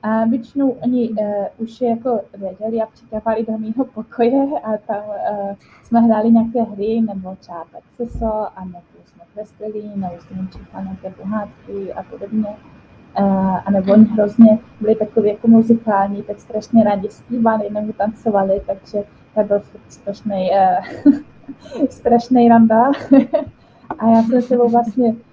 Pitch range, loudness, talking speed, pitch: 205-235 Hz, -17 LUFS, 135 wpm, 220 Hz